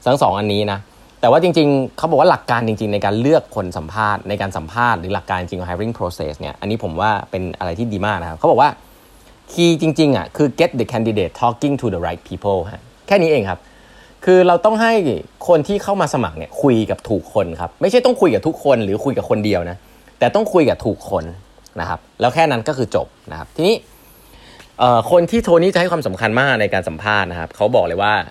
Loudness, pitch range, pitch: -17 LUFS, 95-155 Hz, 110 Hz